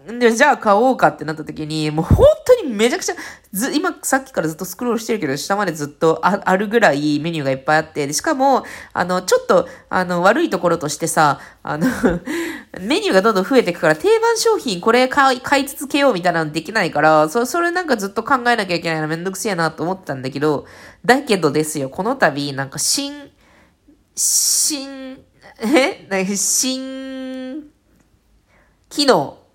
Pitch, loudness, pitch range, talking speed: 220 Hz, -17 LUFS, 160-270 Hz, 380 characters per minute